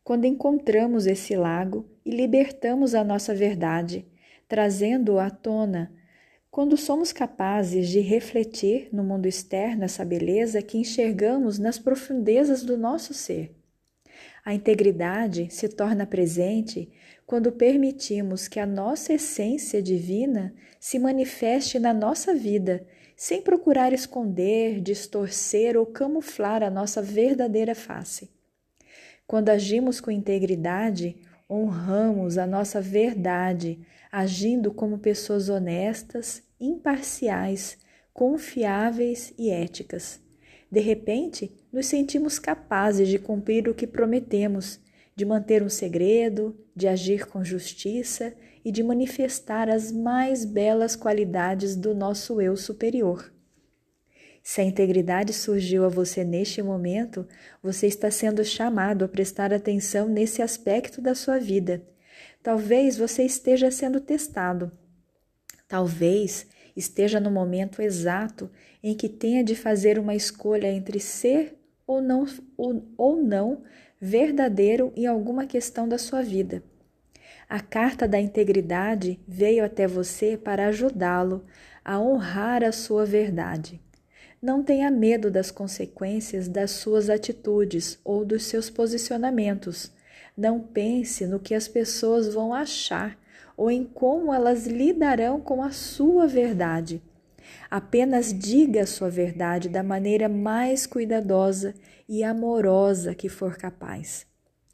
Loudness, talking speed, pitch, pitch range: -25 LUFS, 120 wpm, 215 Hz, 195-240 Hz